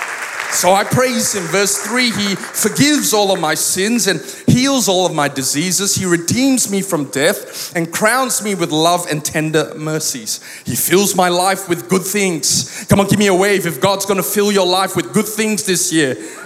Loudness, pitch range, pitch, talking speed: -15 LUFS, 170-205 Hz, 190 Hz, 200 wpm